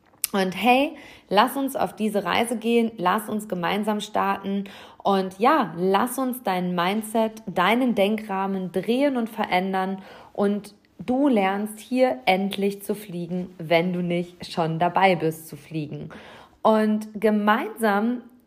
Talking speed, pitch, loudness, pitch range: 130 wpm, 200 Hz, -23 LUFS, 185-225 Hz